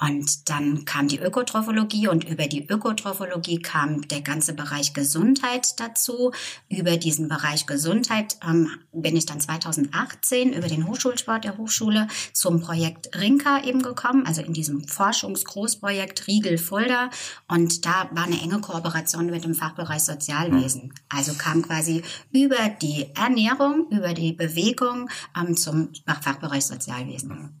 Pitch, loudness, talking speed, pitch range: 170 Hz, -23 LUFS, 135 wpm, 150-215 Hz